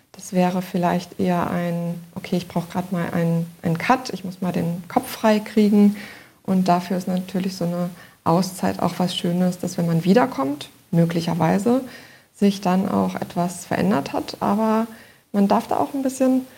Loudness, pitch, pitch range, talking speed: -22 LUFS, 180 Hz, 170-205 Hz, 175 wpm